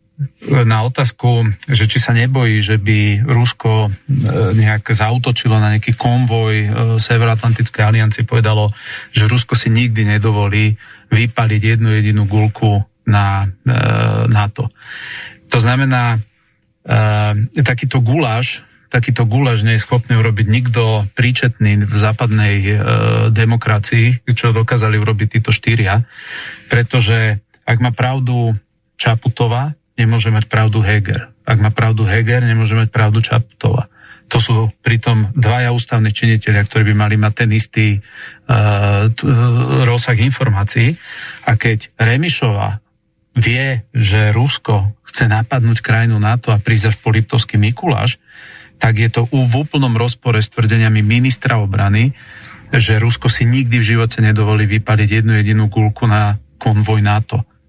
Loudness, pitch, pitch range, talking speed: -14 LUFS, 115 Hz, 110-120 Hz, 130 wpm